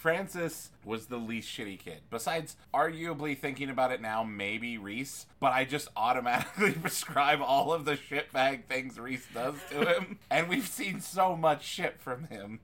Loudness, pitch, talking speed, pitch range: -32 LUFS, 140 Hz, 170 wpm, 120-160 Hz